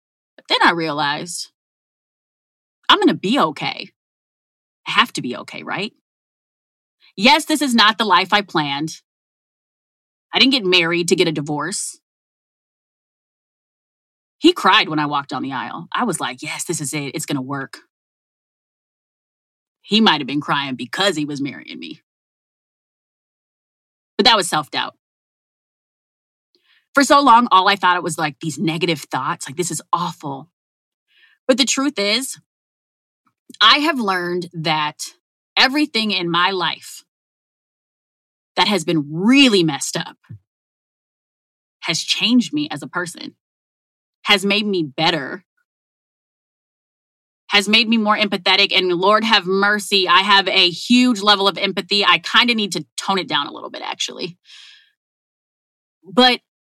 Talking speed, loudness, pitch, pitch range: 145 wpm, -16 LUFS, 185 Hz, 160-225 Hz